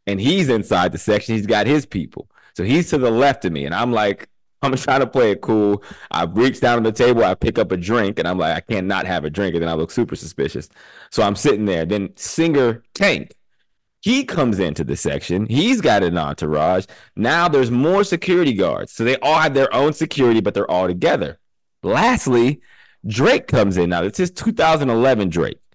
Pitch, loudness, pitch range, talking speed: 115 Hz, -18 LUFS, 100-140 Hz, 210 wpm